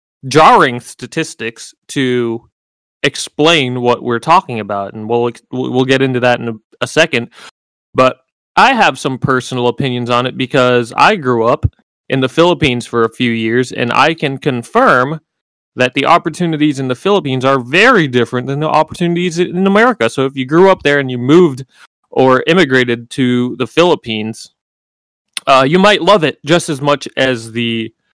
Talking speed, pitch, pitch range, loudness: 170 wpm, 130 Hz, 120-155 Hz, -12 LUFS